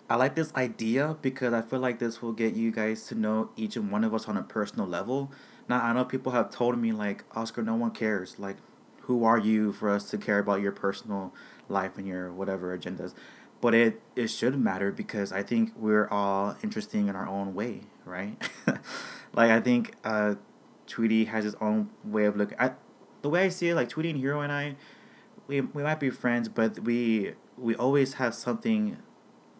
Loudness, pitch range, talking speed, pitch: -29 LUFS, 105-130 Hz, 205 wpm, 115 Hz